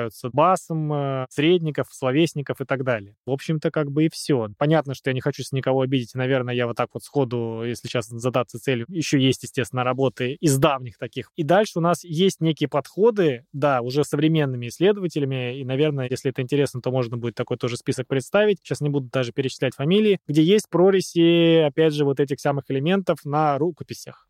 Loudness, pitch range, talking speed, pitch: -22 LUFS, 130-155 Hz, 190 wpm, 140 Hz